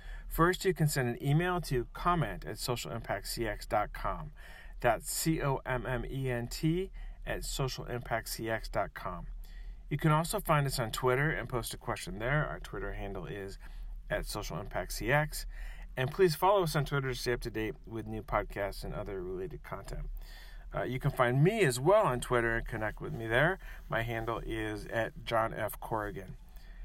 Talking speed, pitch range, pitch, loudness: 160 wpm, 115-160 Hz, 130 Hz, -33 LUFS